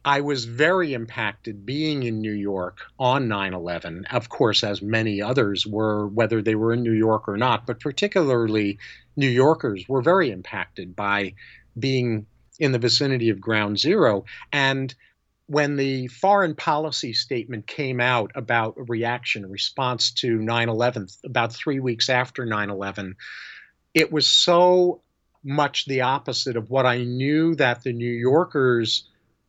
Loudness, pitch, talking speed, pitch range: -22 LUFS, 120 Hz, 155 wpm, 110-135 Hz